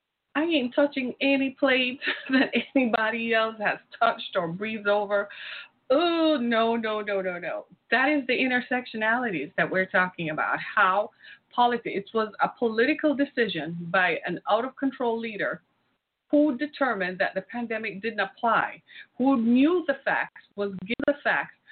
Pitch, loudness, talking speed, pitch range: 235 Hz, -26 LUFS, 150 wpm, 210-270 Hz